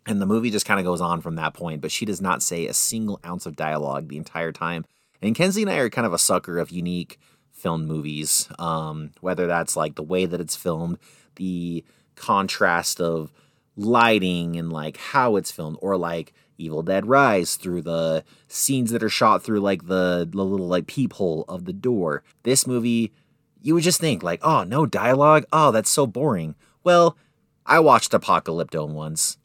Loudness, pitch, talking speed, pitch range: -22 LUFS, 90 Hz, 195 wpm, 80-115 Hz